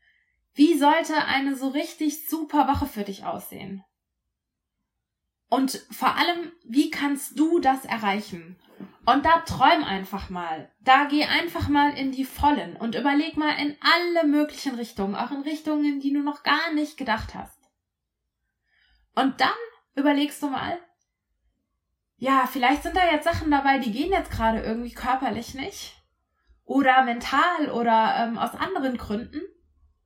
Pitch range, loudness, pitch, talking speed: 240-300 Hz, -24 LUFS, 280 Hz, 145 wpm